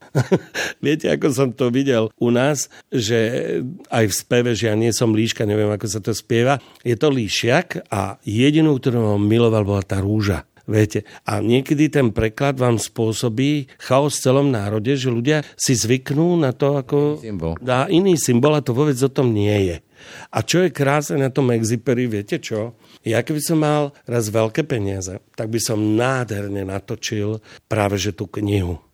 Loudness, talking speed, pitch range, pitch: -19 LUFS, 175 wpm, 105-140 Hz, 120 Hz